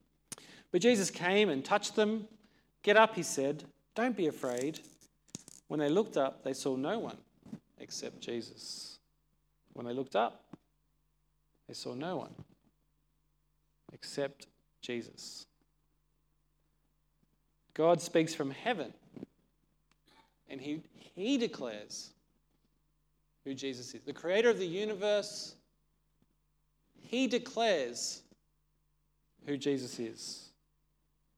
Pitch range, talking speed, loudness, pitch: 140-200 Hz, 105 wpm, -34 LUFS, 150 Hz